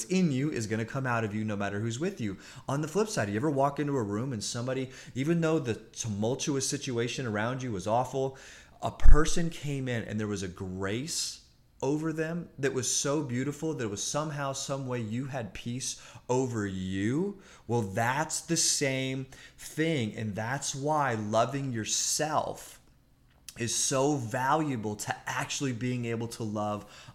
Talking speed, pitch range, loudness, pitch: 180 wpm, 110-145 Hz, -31 LUFS, 130 Hz